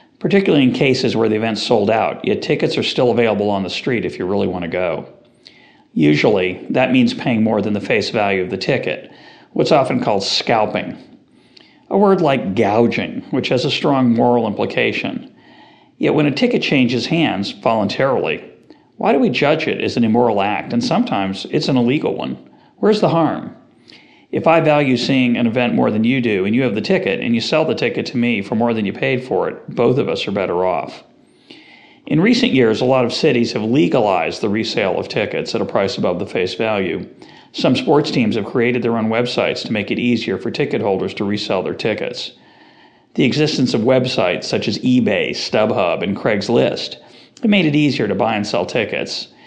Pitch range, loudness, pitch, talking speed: 110-155 Hz, -17 LUFS, 125 Hz, 200 wpm